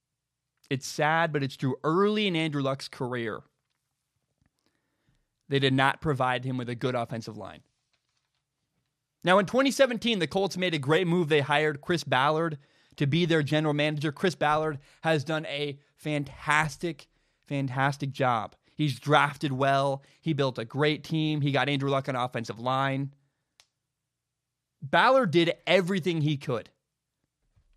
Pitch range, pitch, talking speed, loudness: 135-155 Hz, 145 Hz, 145 wpm, -27 LUFS